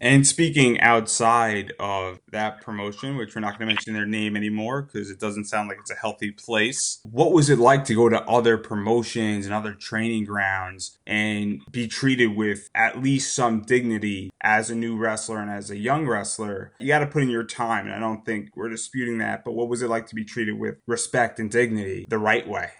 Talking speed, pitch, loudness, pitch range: 220 wpm, 110 Hz, -23 LUFS, 105-120 Hz